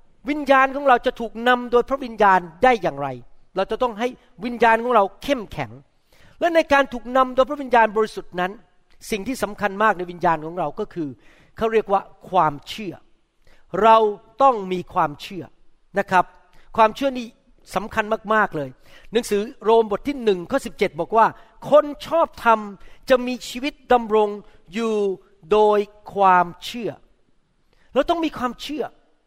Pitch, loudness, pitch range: 220 Hz, -21 LUFS, 185-250 Hz